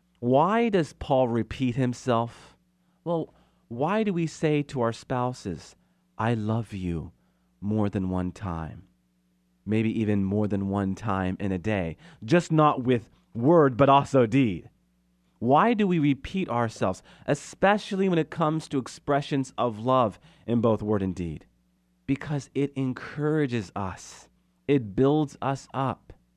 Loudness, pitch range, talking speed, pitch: -26 LUFS, 95-145 Hz, 140 wpm, 120 Hz